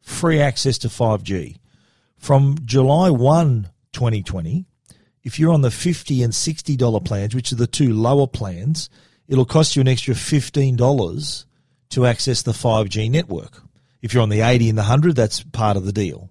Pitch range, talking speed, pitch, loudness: 110-145 Hz, 175 wpm, 125 Hz, -18 LUFS